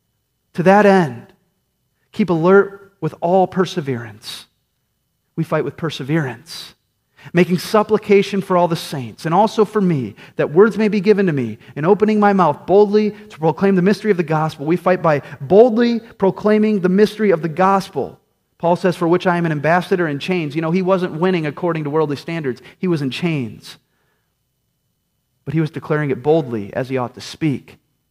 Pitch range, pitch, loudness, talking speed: 145-195 Hz, 175 Hz, -17 LUFS, 180 wpm